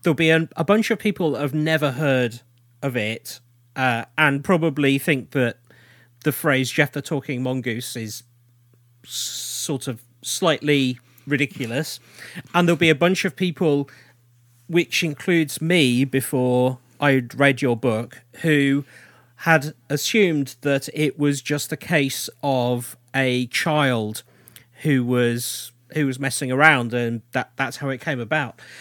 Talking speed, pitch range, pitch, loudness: 140 wpm, 125-150 Hz, 135 Hz, -21 LUFS